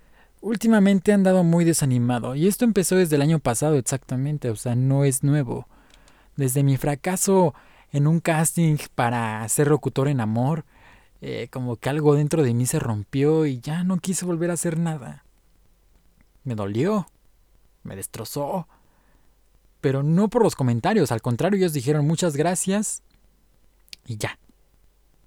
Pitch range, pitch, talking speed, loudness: 130-175 Hz, 150 Hz, 150 wpm, -22 LUFS